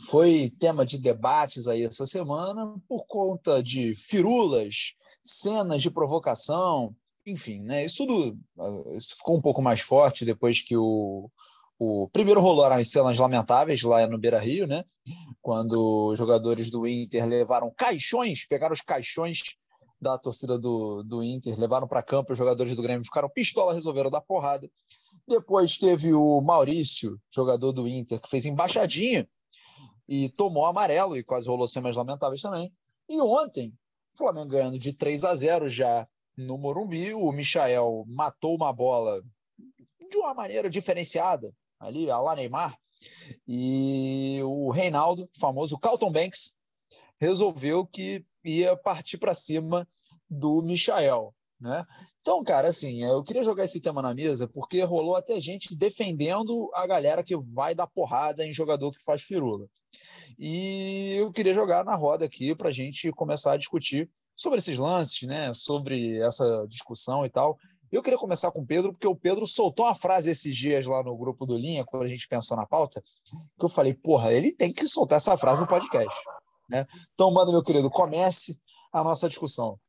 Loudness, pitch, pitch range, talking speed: -26 LUFS, 150 Hz, 125-180 Hz, 165 wpm